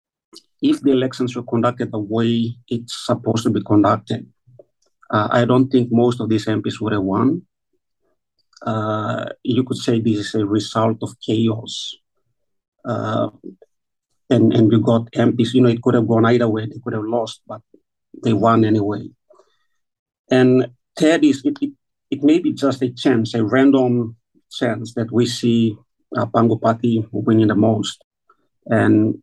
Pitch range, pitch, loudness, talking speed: 110-125 Hz, 115 Hz, -18 LUFS, 160 wpm